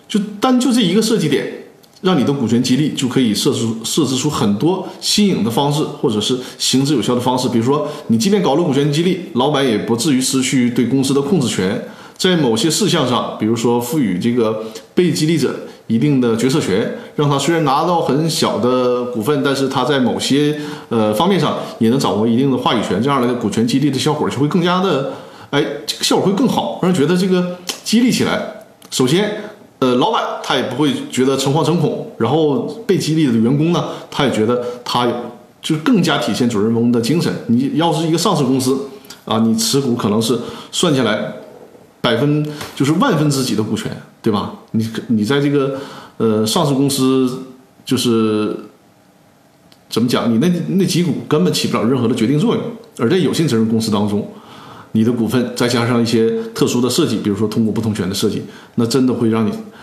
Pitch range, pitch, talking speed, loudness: 120-165 Hz, 140 Hz, 300 characters per minute, -16 LUFS